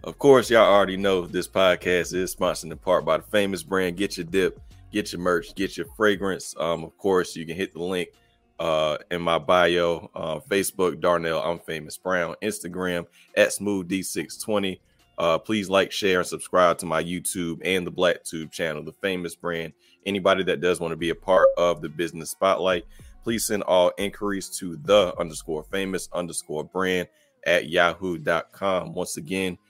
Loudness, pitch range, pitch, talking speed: -24 LUFS, 85-100 Hz, 90 Hz, 180 wpm